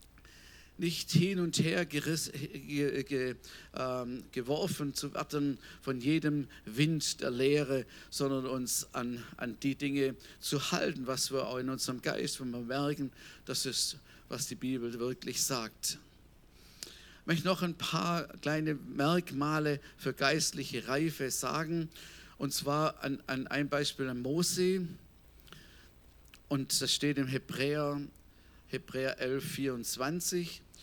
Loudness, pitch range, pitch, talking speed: -34 LUFS, 130-150 Hz, 140 Hz, 130 wpm